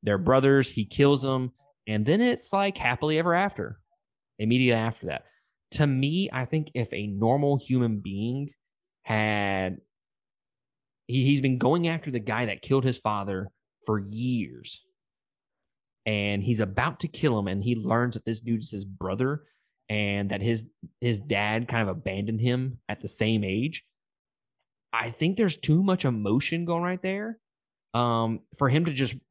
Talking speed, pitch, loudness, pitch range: 165 wpm, 125 Hz, -27 LUFS, 110-145 Hz